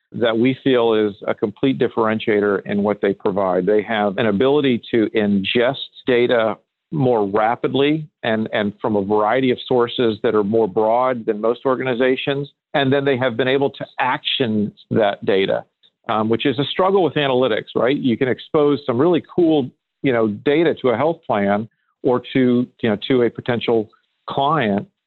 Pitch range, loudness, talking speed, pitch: 110-135 Hz, -19 LUFS, 175 wpm, 120 Hz